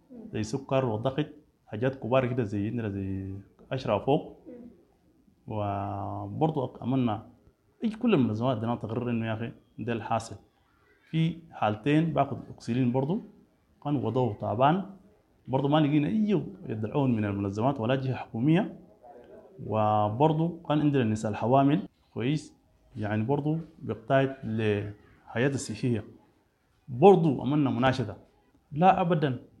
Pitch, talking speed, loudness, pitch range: 130 Hz, 115 wpm, -28 LUFS, 110-150 Hz